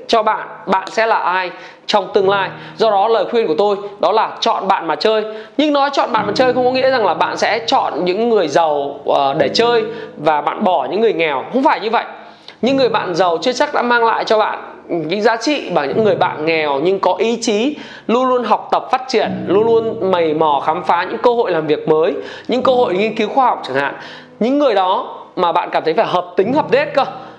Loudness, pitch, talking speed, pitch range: -15 LUFS, 225 Hz, 250 wpm, 190-260 Hz